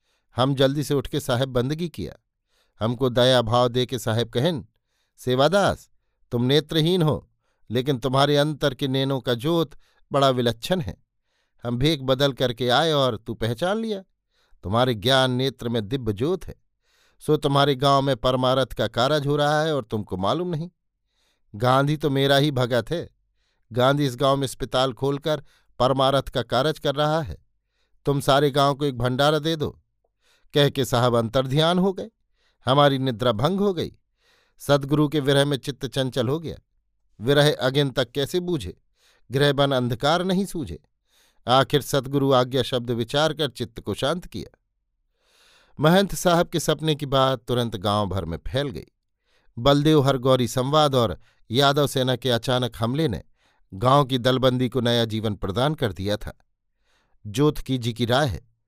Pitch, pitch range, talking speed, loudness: 135 Hz, 125-150 Hz, 165 wpm, -22 LUFS